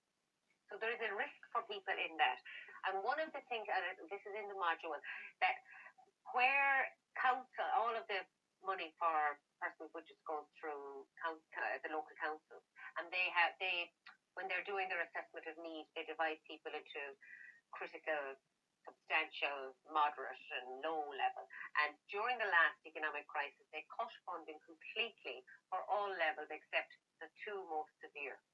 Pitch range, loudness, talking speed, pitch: 155-210 Hz, -41 LUFS, 160 wpm, 165 Hz